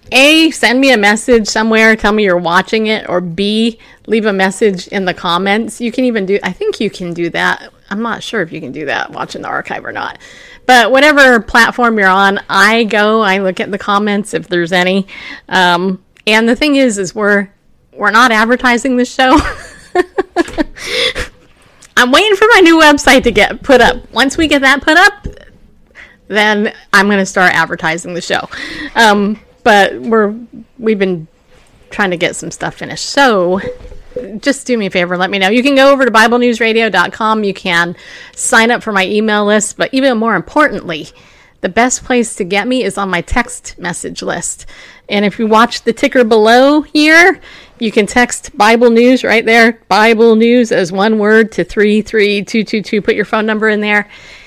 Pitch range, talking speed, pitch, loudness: 200-250 Hz, 190 wpm, 220 Hz, -10 LUFS